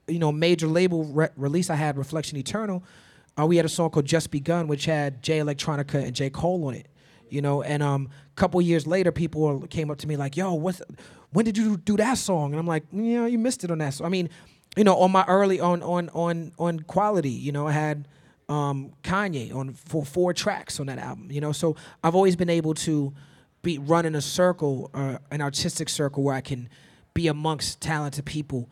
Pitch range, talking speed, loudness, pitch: 145-175 Hz, 225 wpm, -25 LUFS, 160 Hz